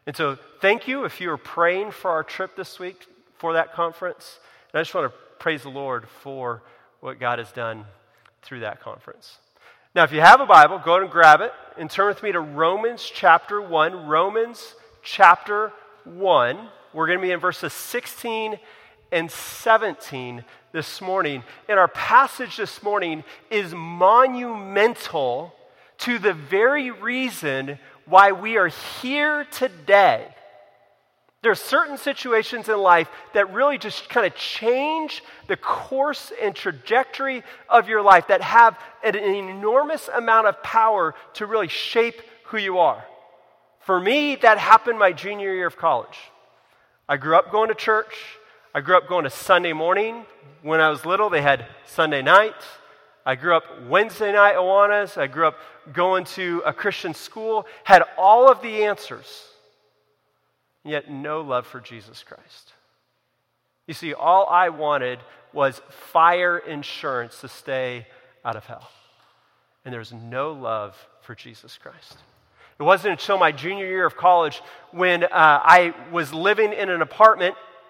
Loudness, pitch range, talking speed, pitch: -19 LUFS, 155-220 Hz, 160 wpm, 185 Hz